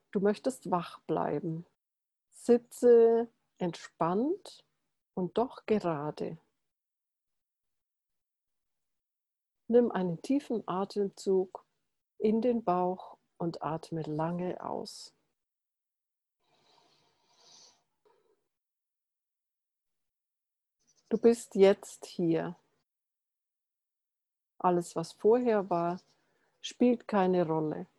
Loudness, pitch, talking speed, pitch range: -30 LUFS, 195 Hz, 65 wpm, 175-235 Hz